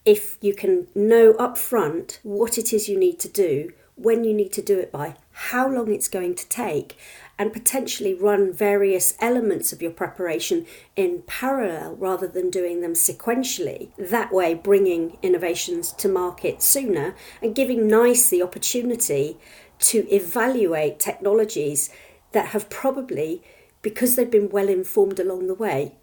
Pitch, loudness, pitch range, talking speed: 210 Hz, -21 LUFS, 190-250 Hz, 150 wpm